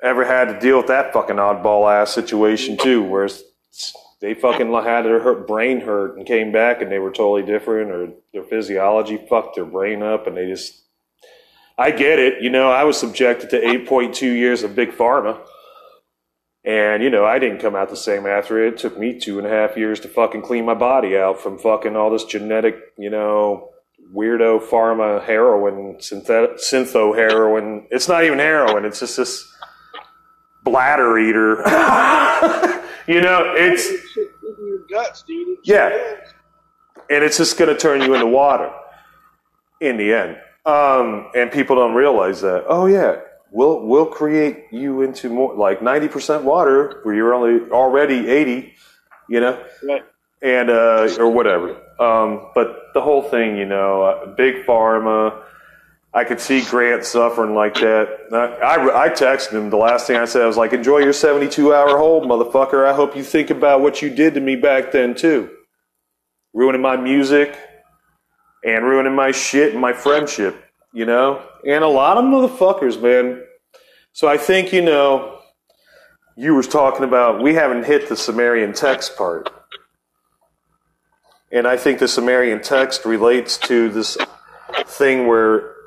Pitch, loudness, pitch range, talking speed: 125 Hz, -16 LUFS, 110-145 Hz, 165 wpm